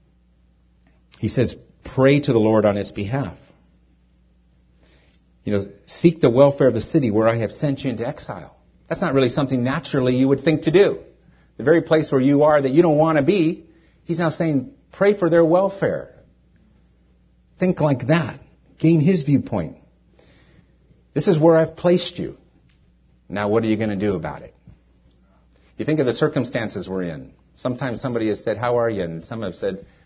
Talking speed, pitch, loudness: 185 wpm, 130 Hz, -20 LUFS